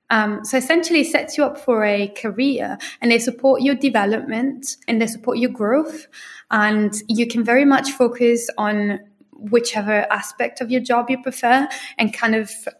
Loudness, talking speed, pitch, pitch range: -19 LUFS, 175 wpm, 240 Hz, 220-265 Hz